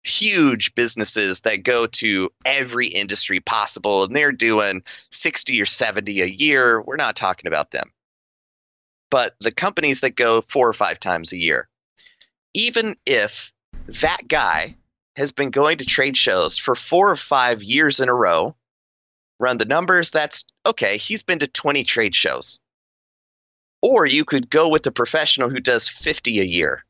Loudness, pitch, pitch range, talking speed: -18 LUFS, 135 Hz, 110-160 Hz, 165 wpm